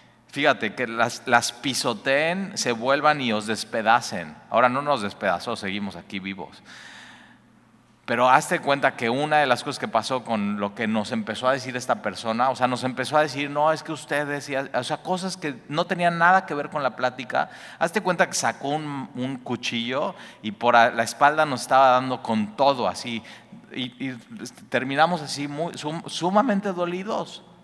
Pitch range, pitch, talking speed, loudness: 120-155 Hz, 135 Hz, 180 wpm, -23 LUFS